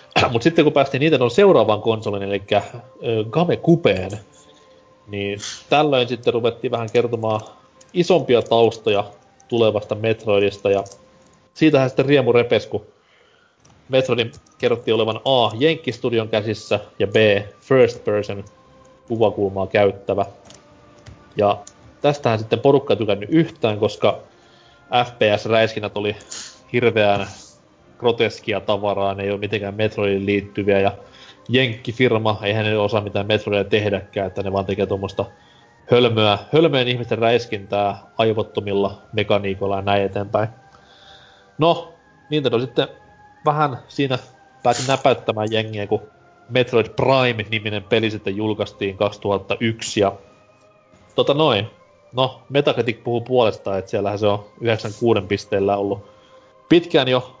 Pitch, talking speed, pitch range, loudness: 110 Hz, 115 wpm, 100-125 Hz, -19 LUFS